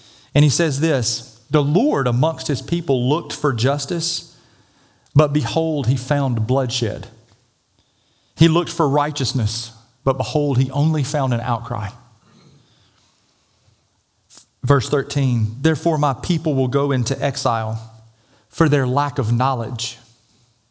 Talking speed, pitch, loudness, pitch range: 120 wpm, 130 Hz, -19 LUFS, 115-145 Hz